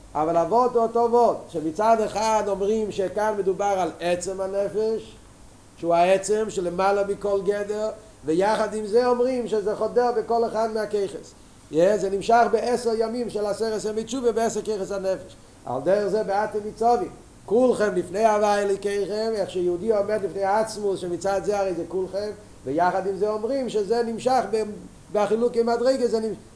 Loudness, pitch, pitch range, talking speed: -24 LUFS, 210 Hz, 195-225 Hz, 155 wpm